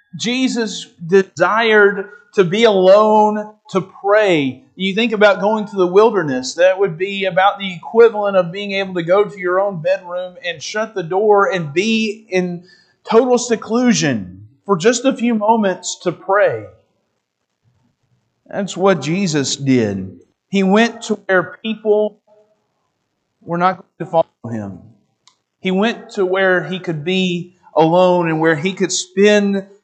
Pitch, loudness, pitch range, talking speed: 195 Hz, -16 LUFS, 180-210 Hz, 145 wpm